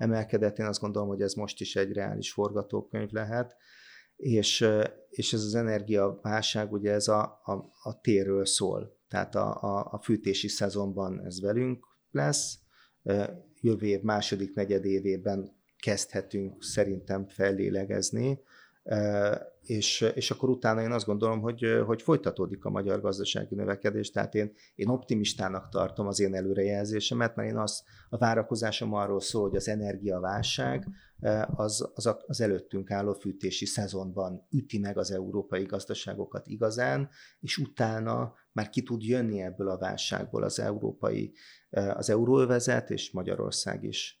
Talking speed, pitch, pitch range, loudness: 135 wpm, 105 Hz, 100-110 Hz, -30 LUFS